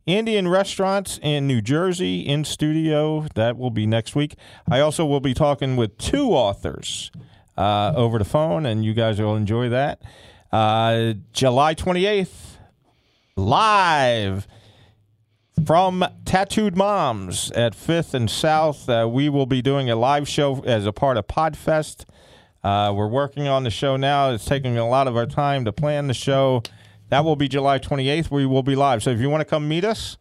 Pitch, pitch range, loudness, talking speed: 135 Hz, 115-150 Hz, -21 LUFS, 175 wpm